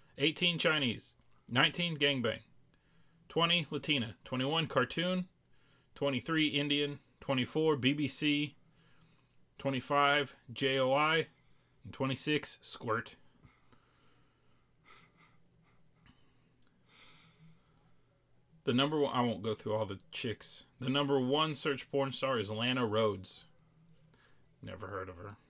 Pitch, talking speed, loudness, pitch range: 140 Hz, 95 wpm, -33 LUFS, 130-155 Hz